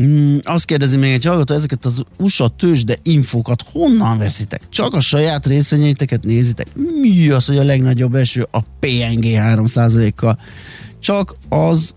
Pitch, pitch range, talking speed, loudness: 135 Hz, 120-150 Hz, 145 wpm, -15 LUFS